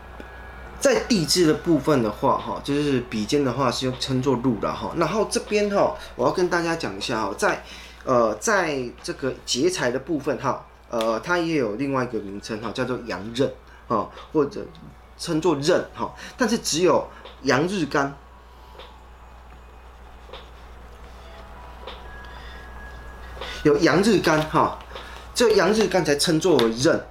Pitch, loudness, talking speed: 120 Hz, -23 LUFS, 195 characters per minute